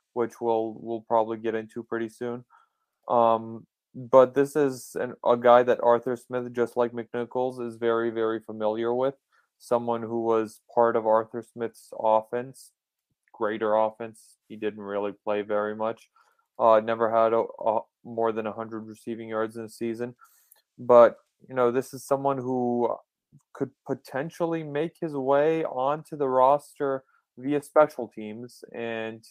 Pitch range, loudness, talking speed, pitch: 115-130 Hz, -26 LUFS, 150 wpm, 120 Hz